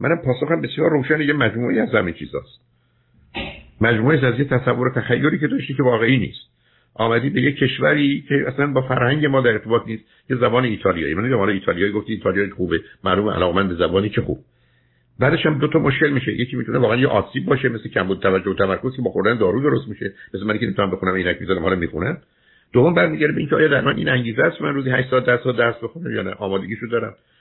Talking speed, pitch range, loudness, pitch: 220 wpm, 100-135 Hz, -19 LUFS, 120 Hz